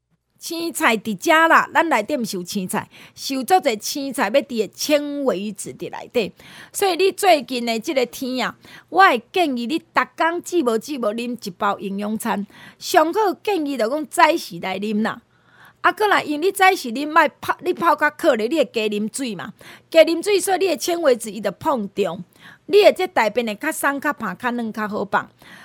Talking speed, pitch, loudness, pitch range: 265 characters per minute, 285 Hz, -20 LUFS, 220-335 Hz